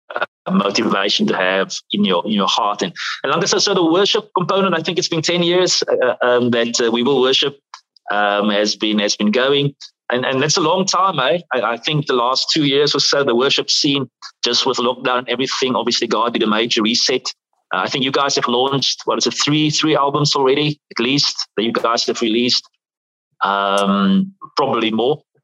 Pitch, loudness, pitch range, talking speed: 135 Hz, -16 LUFS, 115-160 Hz, 215 wpm